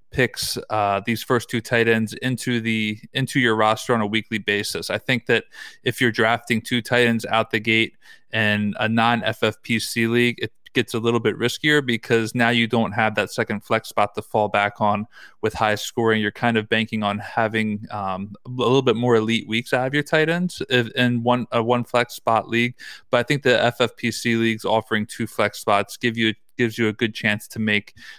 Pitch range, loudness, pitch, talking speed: 110-120 Hz, -21 LUFS, 115 Hz, 210 wpm